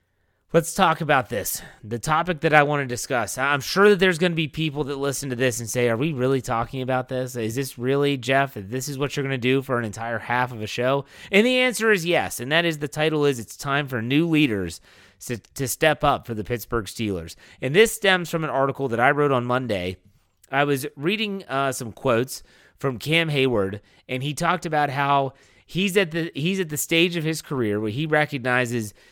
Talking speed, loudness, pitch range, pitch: 225 wpm, -23 LUFS, 120-155 Hz, 135 Hz